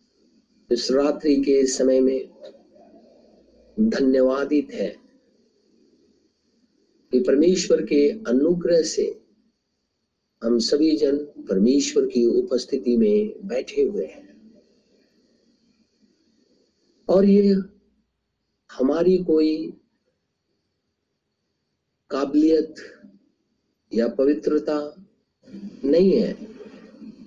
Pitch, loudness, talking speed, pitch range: 185 Hz, -21 LUFS, 65 wpm, 145-230 Hz